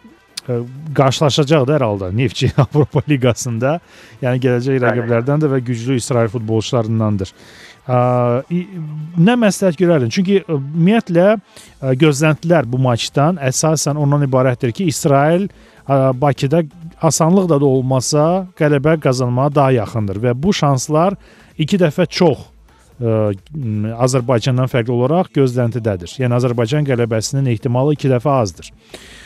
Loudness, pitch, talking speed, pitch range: -16 LUFS, 135 Hz, 115 wpm, 120-155 Hz